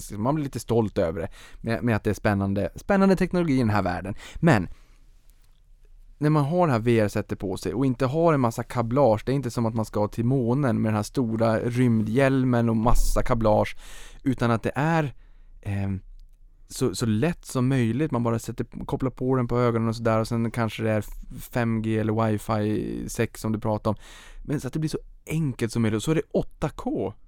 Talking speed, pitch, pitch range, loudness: 215 wpm, 115 Hz, 105-130 Hz, -25 LUFS